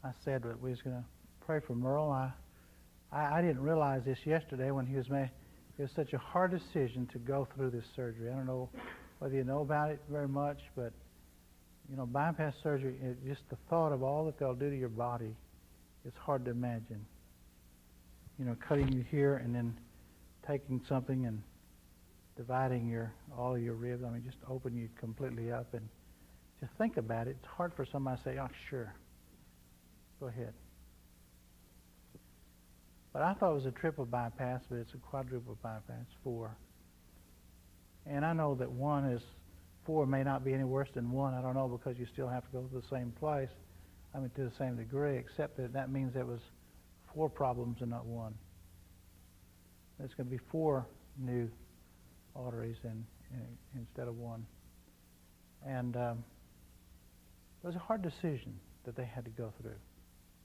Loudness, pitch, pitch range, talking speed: -38 LUFS, 125 Hz, 90-135 Hz, 185 wpm